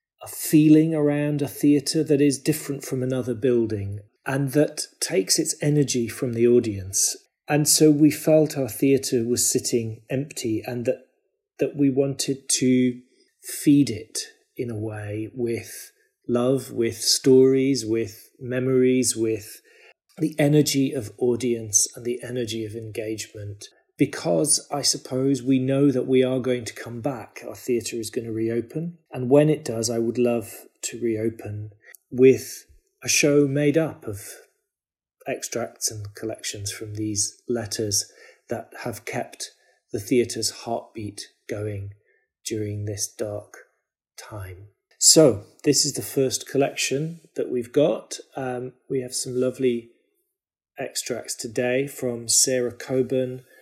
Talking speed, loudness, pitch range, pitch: 140 wpm, -23 LUFS, 115-145 Hz, 125 Hz